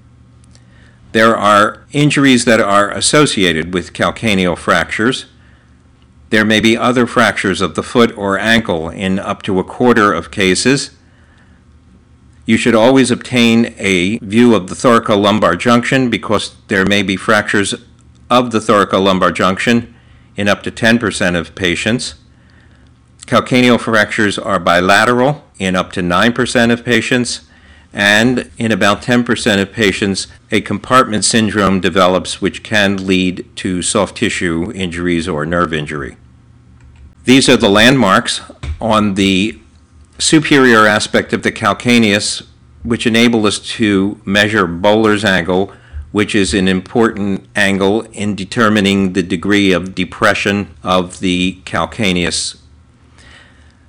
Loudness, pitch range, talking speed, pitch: -13 LUFS, 90-115 Hz, 125 wpm, 100 Hz